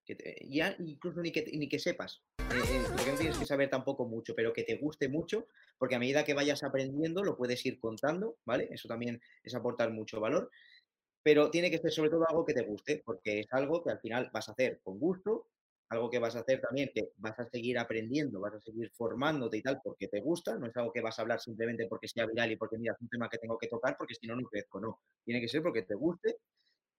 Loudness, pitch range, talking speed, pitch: -35 LUFS, 115-150 Hz, 255 wpm, 125 Hz